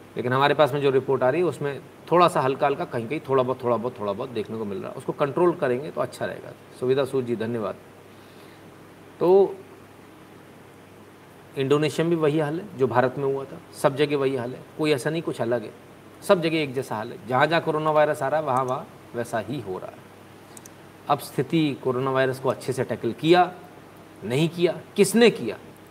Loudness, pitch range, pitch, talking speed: -24 LUFS, 125-155 Hz, 140 Hz, 215 wpm